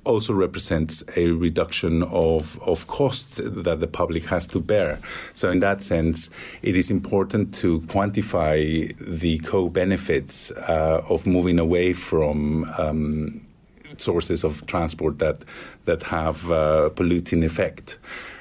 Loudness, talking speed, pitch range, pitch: -22 LUFS, 135 wpm, 80-90 Hz, 85 Hz